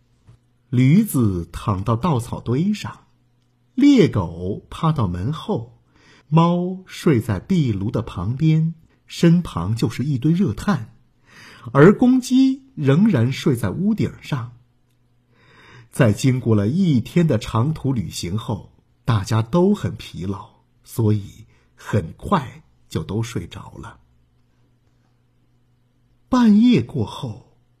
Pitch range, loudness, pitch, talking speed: 110-155 Hz, -20 LUFS, 120 Hz, 155 characters per minute